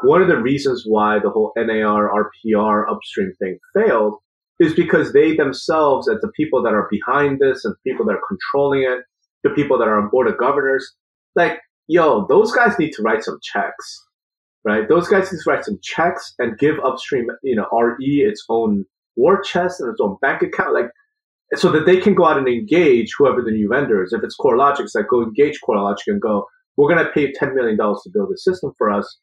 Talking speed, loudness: 215 wpm, -17 LUFS